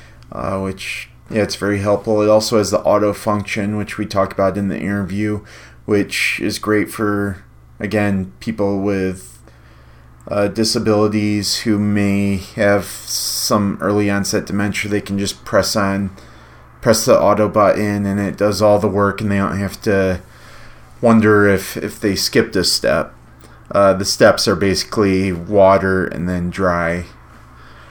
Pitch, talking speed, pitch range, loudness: 100 Hz, 155 wpm, 95-105 Hz, -17 LUFS